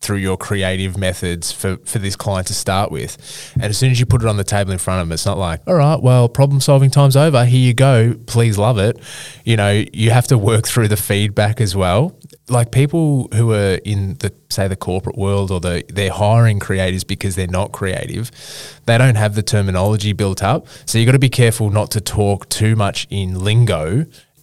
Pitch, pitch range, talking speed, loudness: 110 Hz, 100-125 Hz, 225 wpm, -16 LUFS